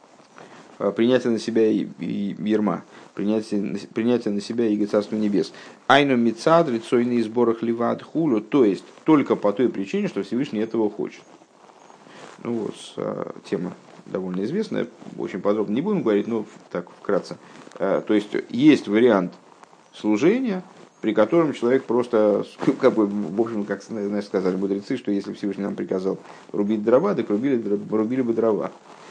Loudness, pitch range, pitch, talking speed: -23 LUFS, 105-120 Hz, 110 Hz, 155 wpm